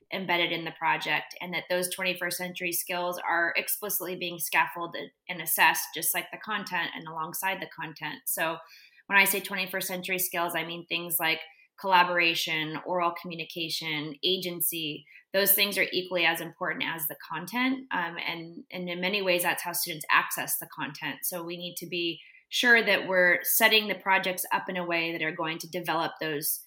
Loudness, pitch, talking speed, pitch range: -27 LUFS, 175 Hz, 180 wpm, 165-185 Hz